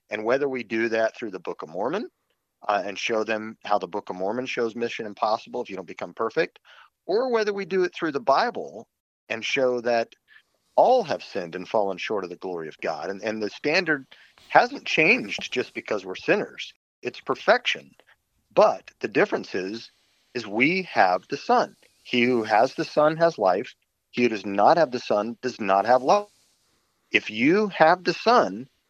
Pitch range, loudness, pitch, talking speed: 110-165 Hz, -24 LUFS, 125 Hz, 195 wpm